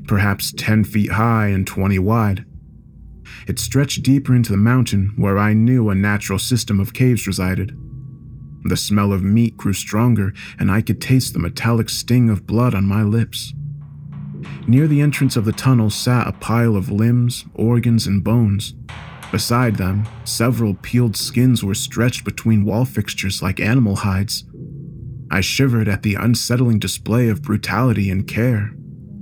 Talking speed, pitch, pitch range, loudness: 160 wpm, 110 Hz, 100-125 Hz, -18 LUFS